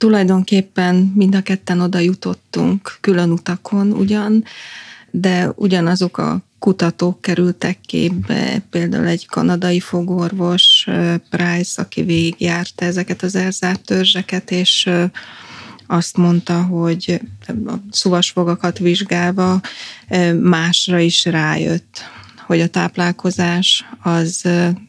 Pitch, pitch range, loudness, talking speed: 180 Hz, 175-190 Hz, -16 LUFS, 95 wpm